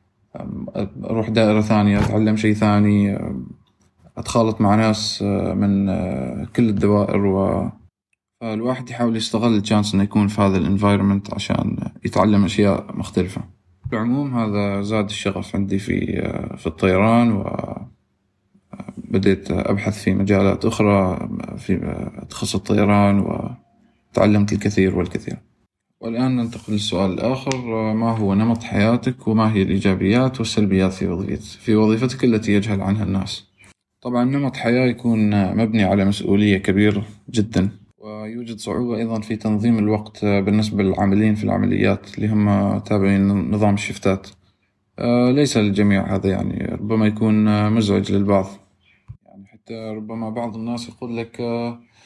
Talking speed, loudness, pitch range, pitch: 120 wpm, -19 LUFS, 100-115 Hz, 105 Hz